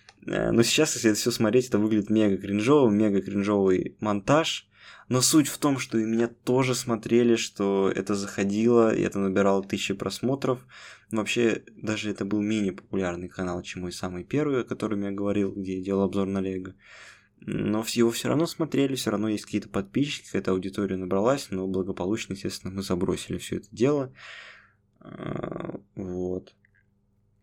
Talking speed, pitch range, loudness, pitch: 160 wpm, 95-115 Hz, -26 LUFS, 105 Hz